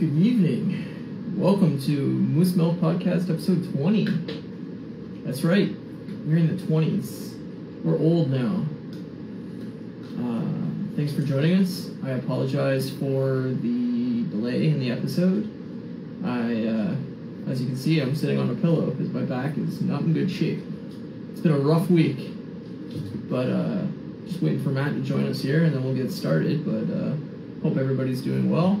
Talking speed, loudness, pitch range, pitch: 160 wpm, -25 LUFS, 135-200 Hz, 170 Hz